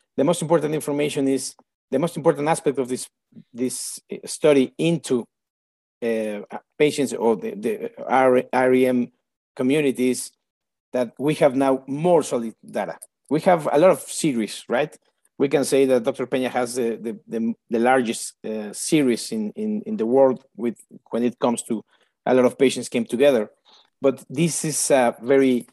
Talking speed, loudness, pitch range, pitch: 165 wpm, -22 LUFS, 120-150 Hz, 130 Hz